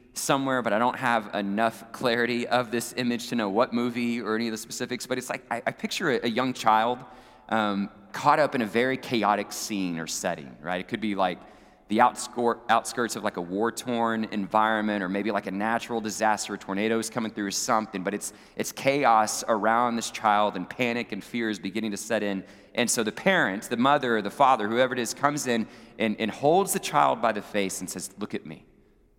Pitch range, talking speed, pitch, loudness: 105-120 Hz, 220 wpm, 110 Hz, -26 LUFS